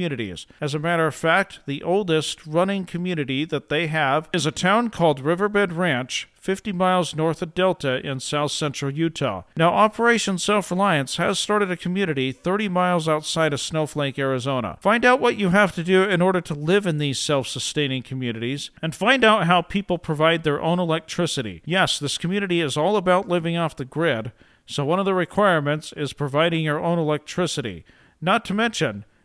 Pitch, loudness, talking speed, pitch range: 165 Hz, -22 LUFS, 185 wpm, 145-185 Hz